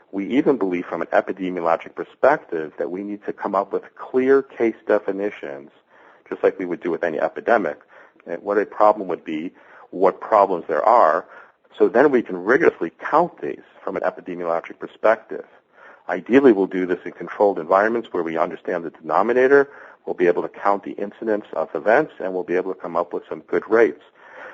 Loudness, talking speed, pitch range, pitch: -21 LUFS, 190 wpm, 90-130 Hz, 100 Hz